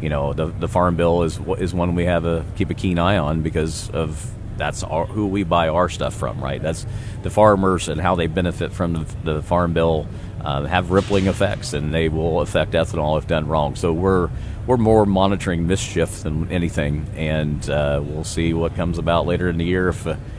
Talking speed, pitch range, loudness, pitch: 215 wpm, 80-95 Hz, -20 LUFS, 85 Hz